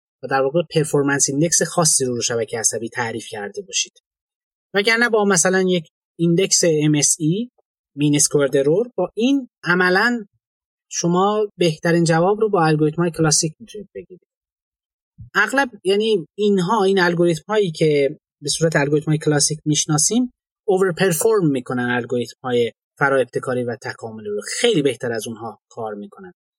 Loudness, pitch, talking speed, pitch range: -18 LUFS, 170 Hz, 140 wpm, 145-200 Hz